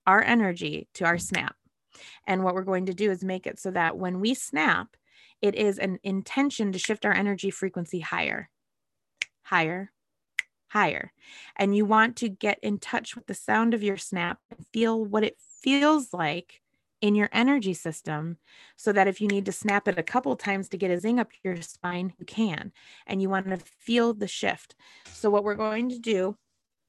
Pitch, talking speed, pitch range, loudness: 200 Hz, 195 wpm, 185-220 Hz, -27 LUFS